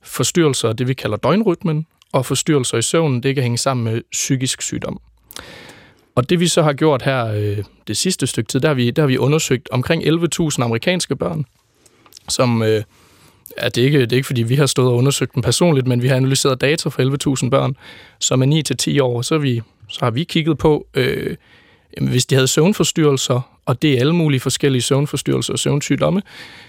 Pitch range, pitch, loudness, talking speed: 125-155 Hz, 135 Hz, -17 LUFS, 200 wpm